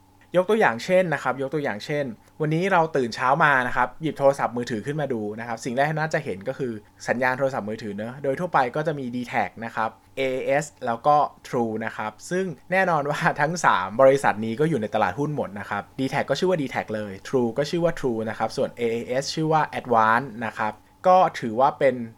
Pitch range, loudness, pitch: 110-150 Hz, -24 LUFS, 130 Hz